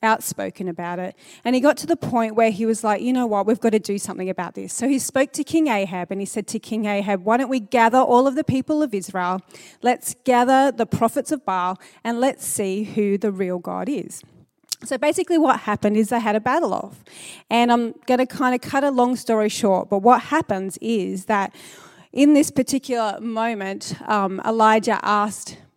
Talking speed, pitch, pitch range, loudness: 215 wpm, 225 Hz, 200-255 Hz, -21 LUFS